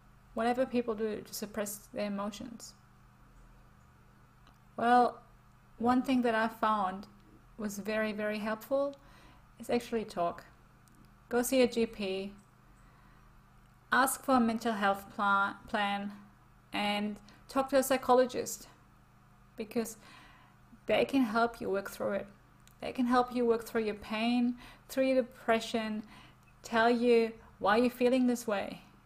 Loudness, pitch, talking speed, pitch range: -32 LUFS, 225 Hz, 125 wpm, 205-245 Hz